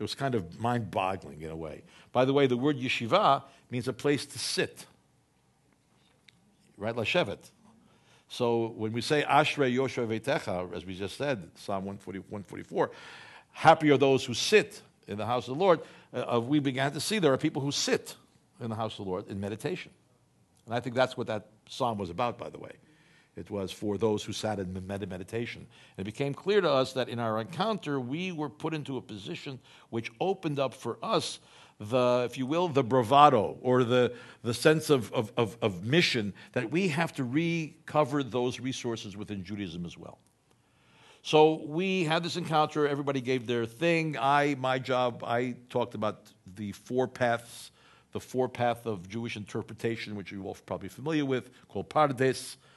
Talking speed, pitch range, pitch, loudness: 180 wpm, 110-145 Hz, 125 Hz, -29 LUFS